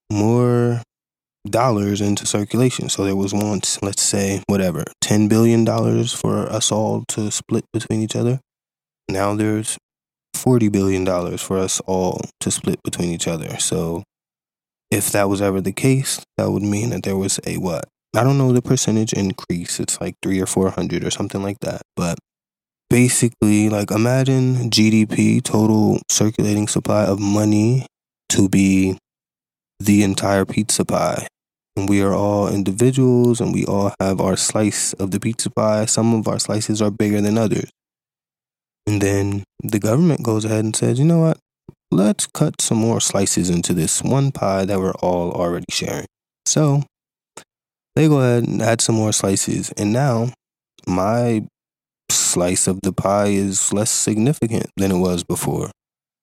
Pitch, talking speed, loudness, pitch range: 105 Hz, 160 wpm, -18 LUFS, 100-115 Hz